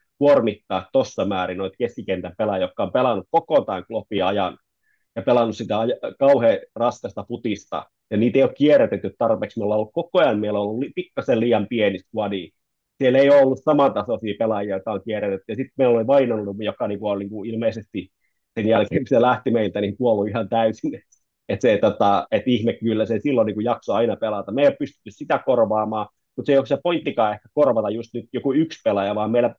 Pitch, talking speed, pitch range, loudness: 115 Hz, 200 wpm, 105-140 Hz, -21 LUFS